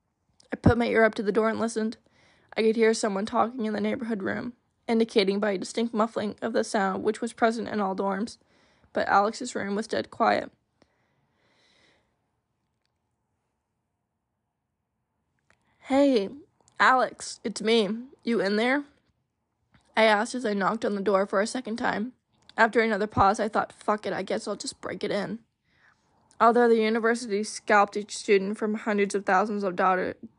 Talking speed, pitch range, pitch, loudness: 170 wpm, 200-230 Hz, 215 Hz, -26 LUFS